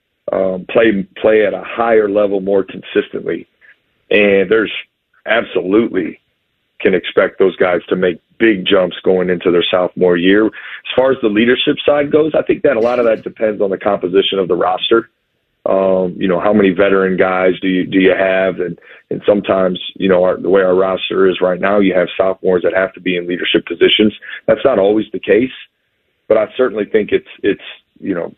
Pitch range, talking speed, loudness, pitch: 95-110 Hz, 200 wpm, -14 LUFS, 95 Hz